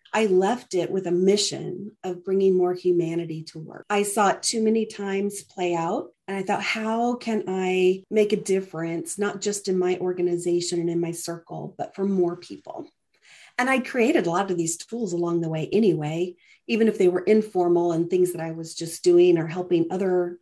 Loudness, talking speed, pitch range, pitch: -24 LUFS, 205 wpm, 175-205 Hz, 180 Hz